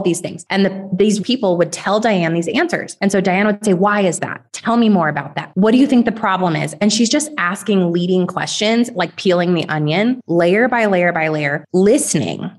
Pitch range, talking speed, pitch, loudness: 170-210 Hz, 225 wpm, 190 Hz, -16 LUFS